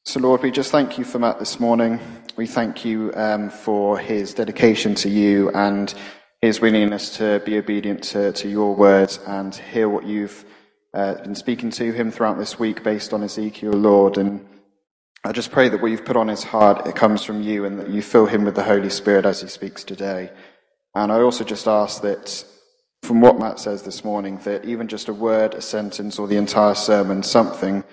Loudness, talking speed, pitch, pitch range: -19 LUFS, 205 wpm, 105 Hz, 100-110 Hz